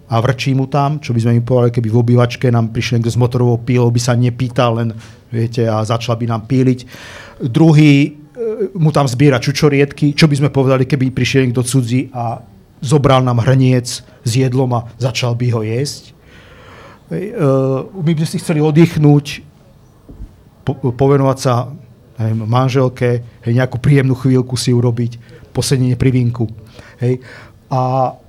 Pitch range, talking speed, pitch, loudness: 120-140 Hz, 145 wpm, 125 Hz, -14 LUFS